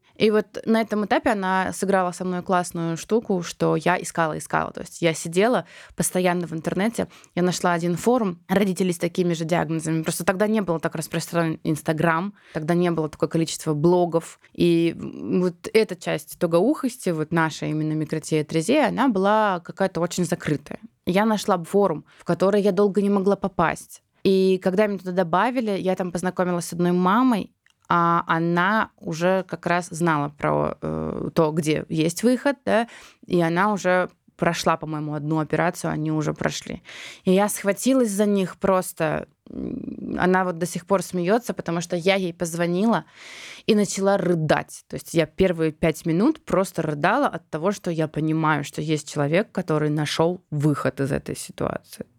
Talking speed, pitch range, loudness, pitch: 165 wpm, 165-200 Hz, -23 LUFS, 175 Hz